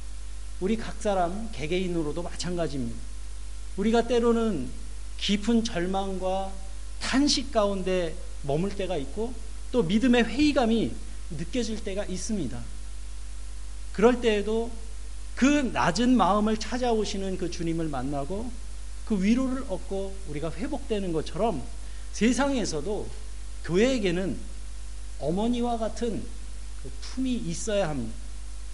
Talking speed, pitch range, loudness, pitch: 255 characters per minute, 150-230 Hz, -28 LUFS, 195 Hz